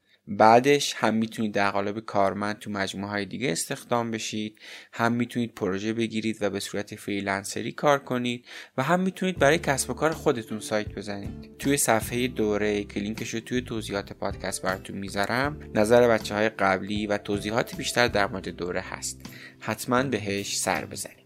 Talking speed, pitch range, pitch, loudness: 165 wpm, 100-120 Hz, 110 Hz, -26 LUFS